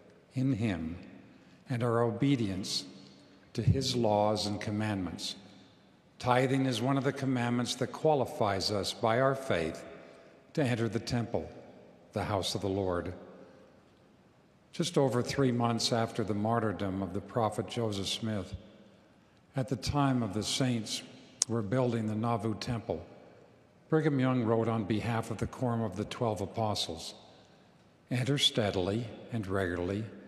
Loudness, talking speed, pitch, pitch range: -32 LUFS, 140 wpm, 115 Hz, 100-125 Hz